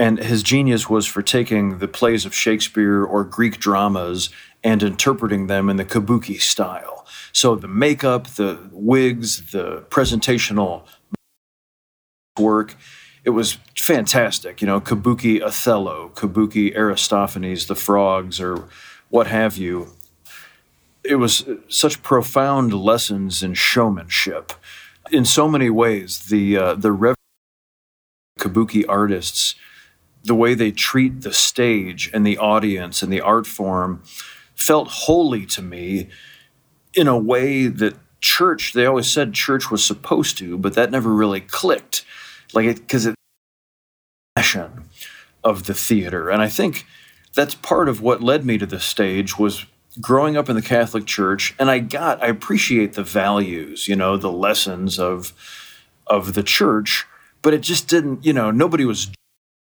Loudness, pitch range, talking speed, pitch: -18 LUFS, 95-115 Hz, 145 wpm, 105 Hz